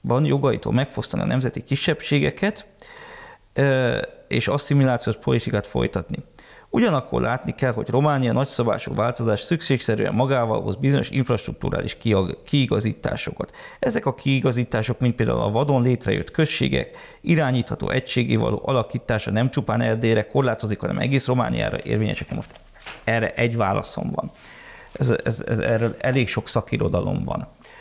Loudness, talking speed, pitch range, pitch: -22 LUFS, 120 wpm, 110-140 Hz, 125 Hz